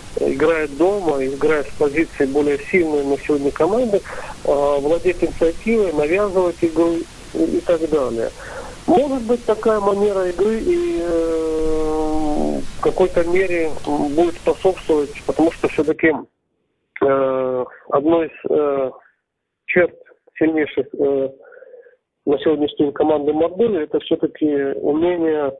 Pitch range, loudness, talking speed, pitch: 145-195 Hz, -19 LUFS, 110 wpm, 160 Hz